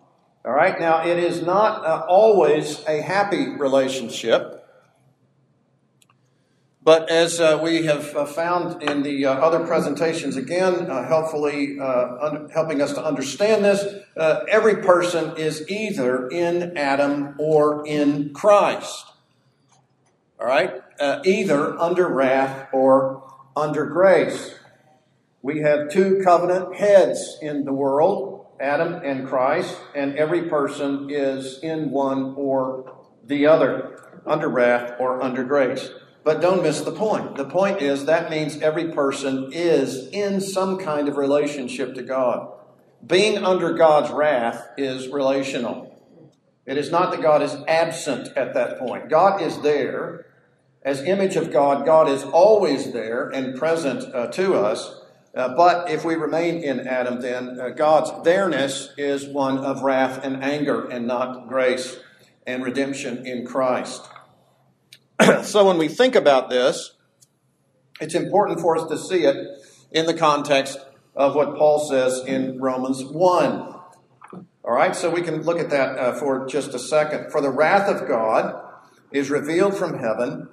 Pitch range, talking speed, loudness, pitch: 135-165 Hz, 145 wpm, -21 LUFS, 150 Hz